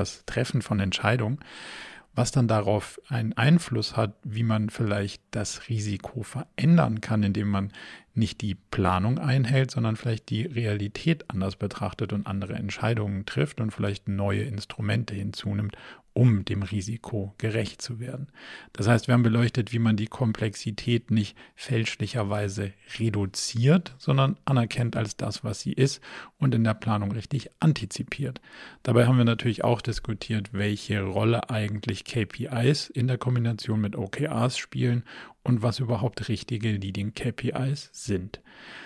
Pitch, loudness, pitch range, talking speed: 115 Hz, -27 LUFS, 105-125 Hz, 140 wpm